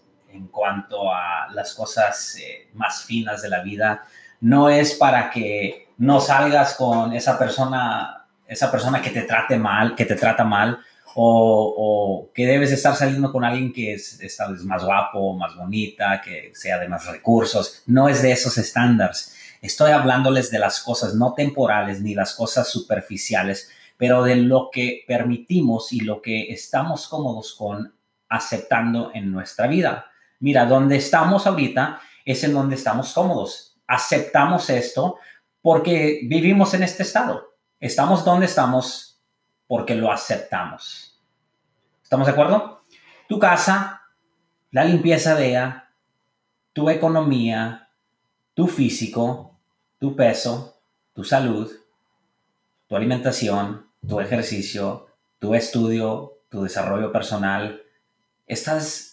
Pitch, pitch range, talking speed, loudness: 125 Hz, 110-140 Hz, 130 wpm, -20 LUFS